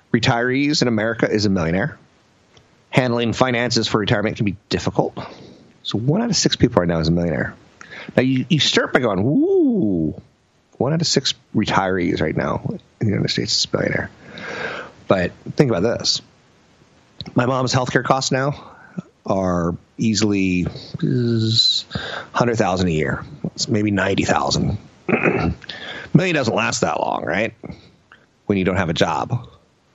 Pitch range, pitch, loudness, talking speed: 95-130 Hz, 115 Hz, -19 LUFS, 150 wpm